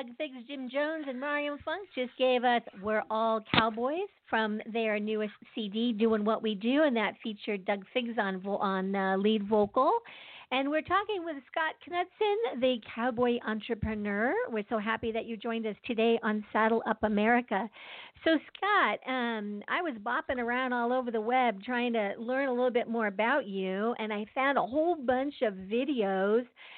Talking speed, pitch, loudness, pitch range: 180 wpm, 235 Hz, -30 LUFS, 215-265 Hz